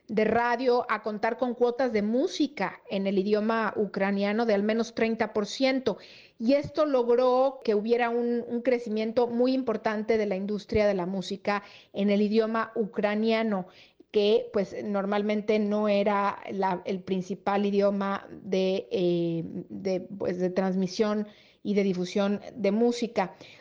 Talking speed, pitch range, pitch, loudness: 145 wpm, 200-235 Hz, 210 Hz, -27 LUFS